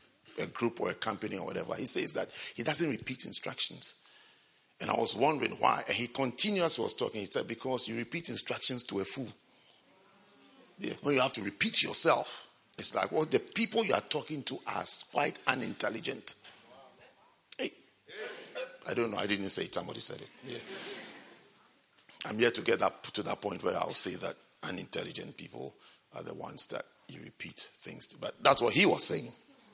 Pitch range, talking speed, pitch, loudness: 115-190 Hz, 190 wpm, 130 Hz, -32 LUFS